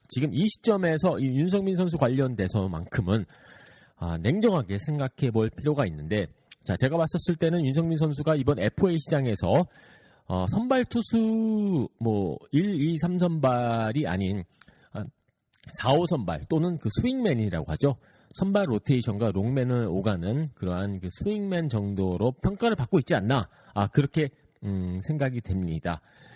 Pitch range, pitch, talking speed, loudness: 105-165 Hz, 135 Hz, 280 characters per minute, -27 LUFS